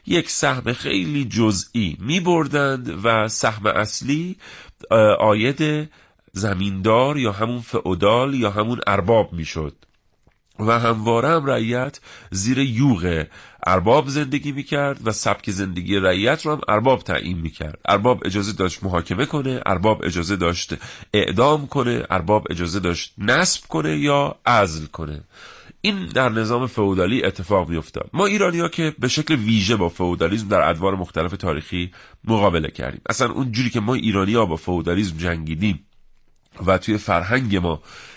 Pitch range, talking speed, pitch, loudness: 90-130 Hz, 145 wpm, 110 Hz, -20 LUFS